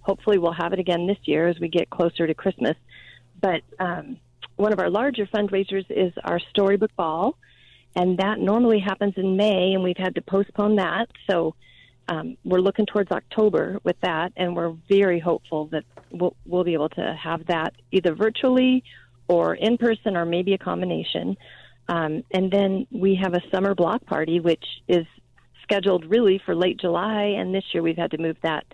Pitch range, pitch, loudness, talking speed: 170-205 Hz, 185 Hz, -23 LUFS, 185 wpm